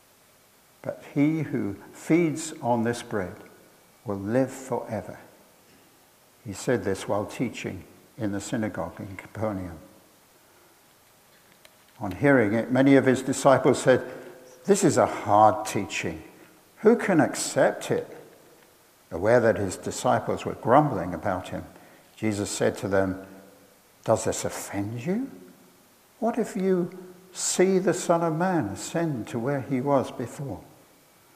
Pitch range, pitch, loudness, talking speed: 100-155 Hz, 125 Hz, -25 LUFS, 130 wpm